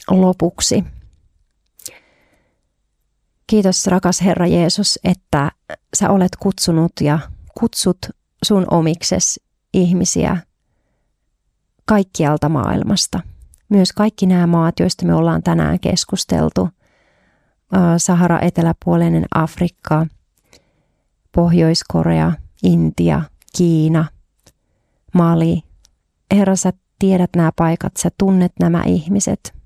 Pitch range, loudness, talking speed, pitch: 150-185 Hz, -16 LUFS, 85 wpm, 170 Hz